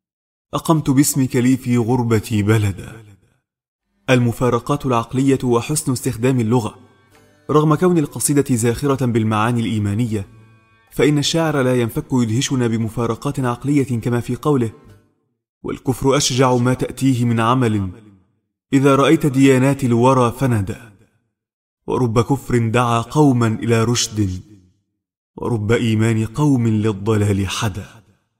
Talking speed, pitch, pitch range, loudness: 105 wpm, 120 Hz, 110-130 Hz, -17 LUFS